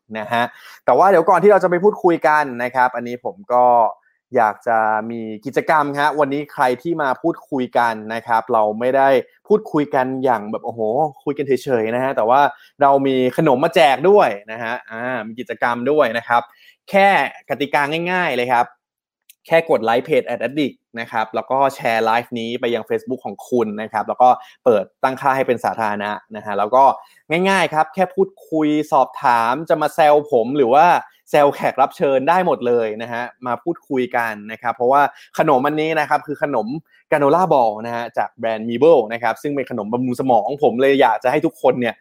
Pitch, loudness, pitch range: 125 Hz, -18 LUFS, 115-150 Hz